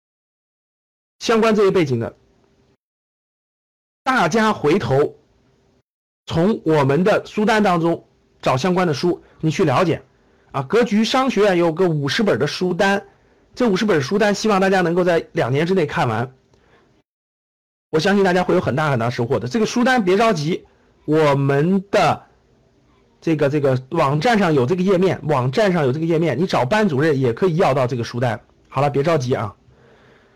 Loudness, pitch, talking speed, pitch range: -18 LUFS, 170 Hz, 245 characters per minute, 140-200 Hz